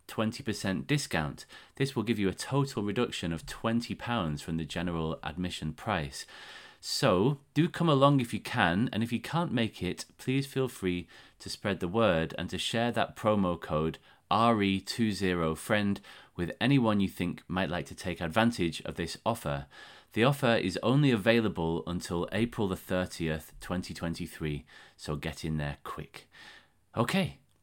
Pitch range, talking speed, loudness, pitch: 85-115 Hz, 155 wpm, -31 LUFS, 100 Hz